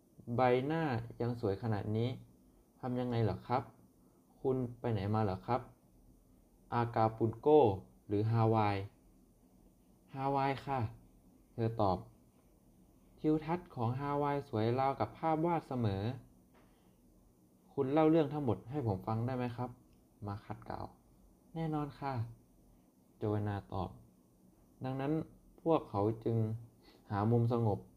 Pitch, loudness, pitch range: 115 Hz, -36 LUFS, 95-130 Hz